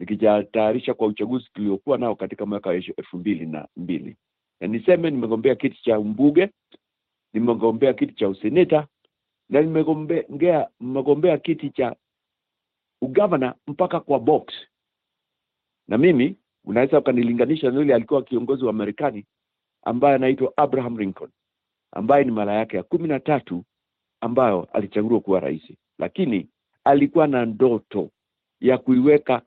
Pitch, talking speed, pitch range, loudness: 130 Hz, 125 wpm, 110-150 Hz, -21 LUFS